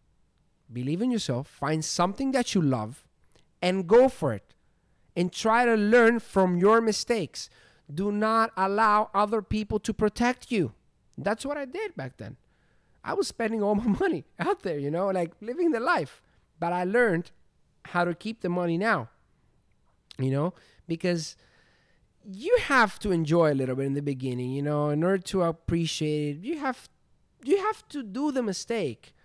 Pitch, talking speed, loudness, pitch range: 195 Hz, 170 wpm, -27 LUFS, 165-230 Hz